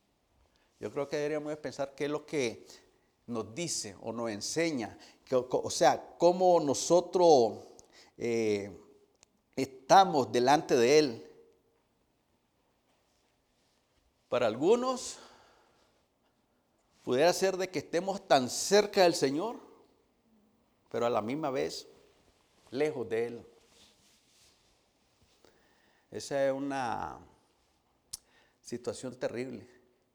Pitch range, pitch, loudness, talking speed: 125-195 Hz, 150 Hz, -30 LUFS, 100 wpm